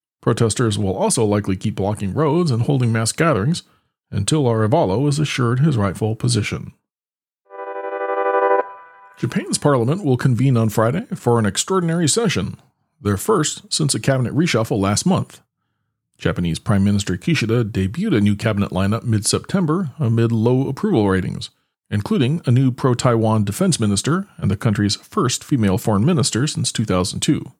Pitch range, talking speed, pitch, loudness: 100-145 Hz, 145 wpm, 115 Hz, -19 LUFS